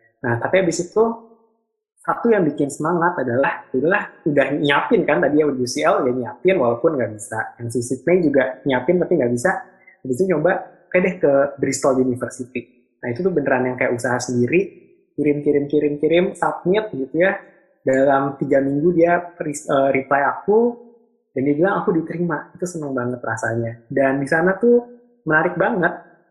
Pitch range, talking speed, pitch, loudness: 135-185 Hz, 175 wpm, 155 Hz, -19 LUFS